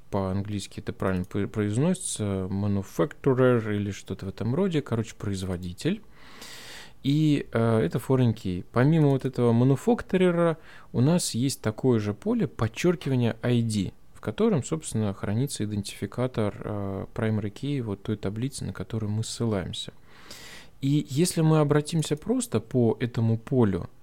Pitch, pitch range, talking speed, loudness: 115 Hz, 105-140 Hz, 130 wpm, -27 LUFS